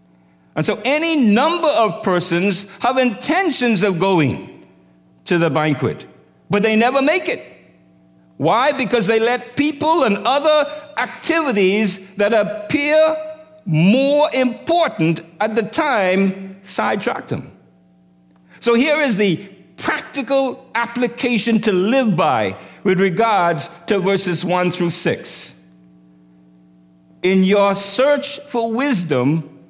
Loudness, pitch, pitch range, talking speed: -17 LUFS, 205 Hz, 165-265 Hz, 115 wpm